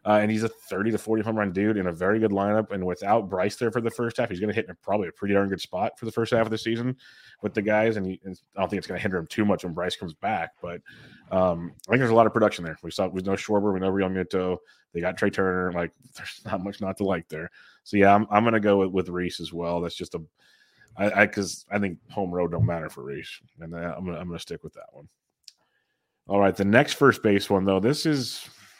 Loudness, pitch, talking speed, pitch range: -25 LUFS, 100 Hz, 285 wpm, 90-110 Hz